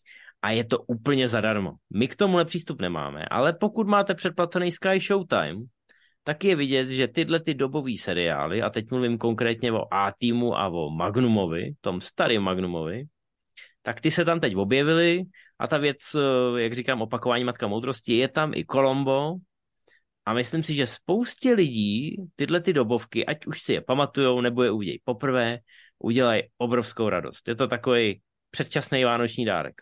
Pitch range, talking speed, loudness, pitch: 115-160 Hz, 165 wpm, -25 LUFS, 125 Hz